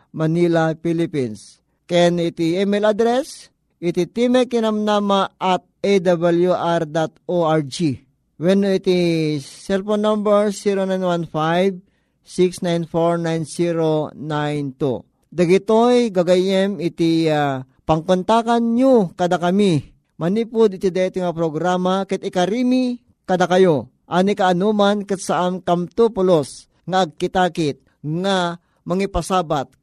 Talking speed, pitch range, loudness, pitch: 85 wpm, 165-195 Hz, -19 LUFS, 180 Hz